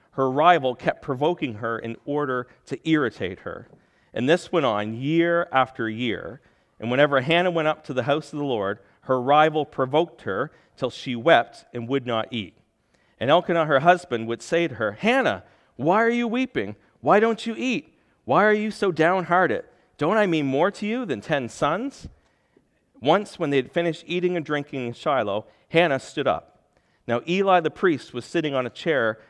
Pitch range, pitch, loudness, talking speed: 125-180 Hz, 155 Hz, -23 LUFS, 190 wpm